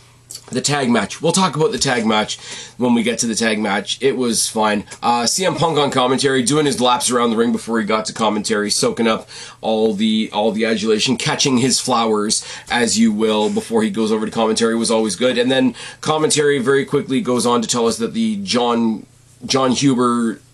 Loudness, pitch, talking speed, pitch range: -17 LUFS, 125 Hz, 215 wpm, 110-140 Hz